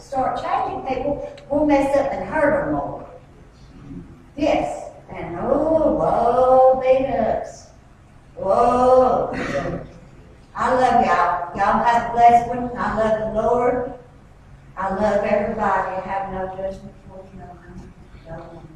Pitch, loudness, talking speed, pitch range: 245 Hz, -19 LUFS, 130 wpm, 195-260 Hz